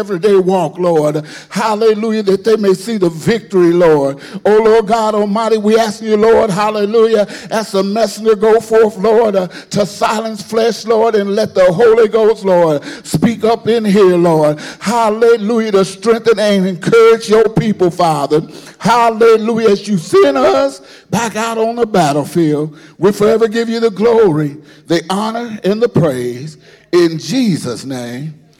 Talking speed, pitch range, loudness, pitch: 155 wpm, 175-225 Hz, -12 LUFS, 210 Hz